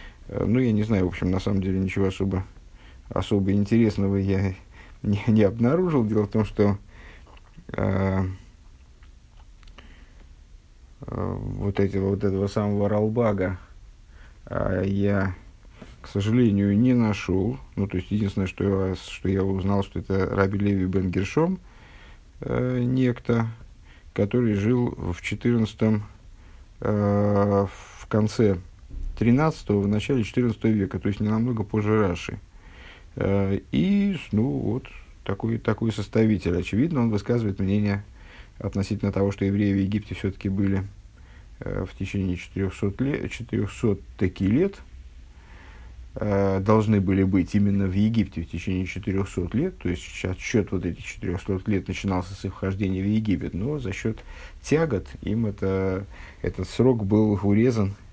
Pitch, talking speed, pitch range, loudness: 100 Hz, 130 wpm, 95-110 Hz, -25 LUFS